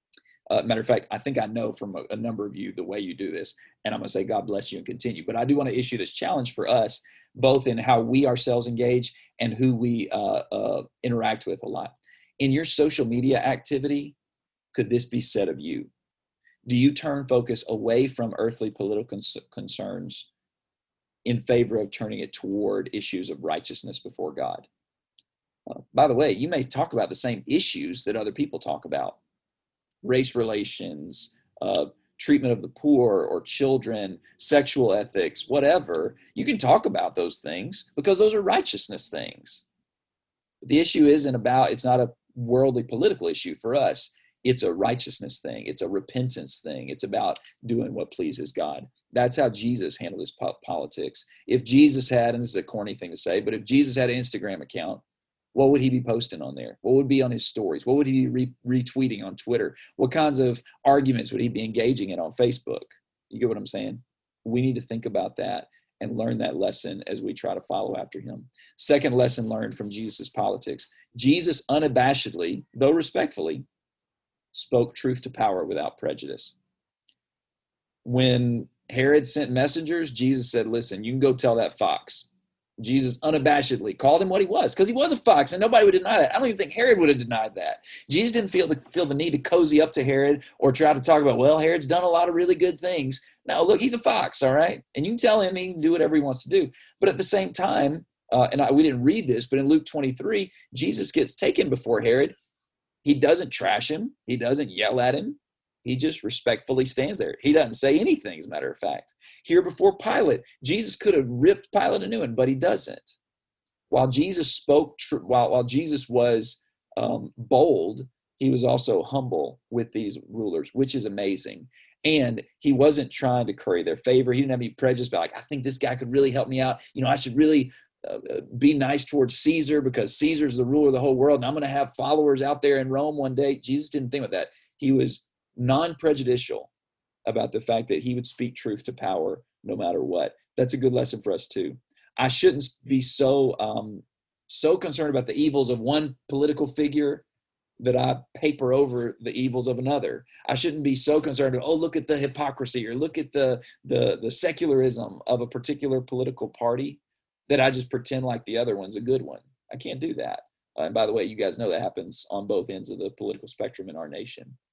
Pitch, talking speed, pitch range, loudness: 135 Hz, 210 wpm, 125-150 Hz, -24 LUFS